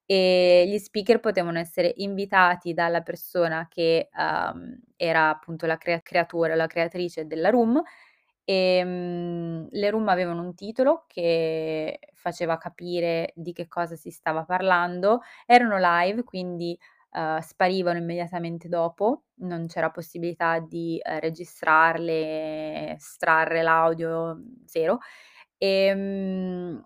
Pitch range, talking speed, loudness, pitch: 165-190 Hz, 115 wpm, -25 LUFS, 175 Hz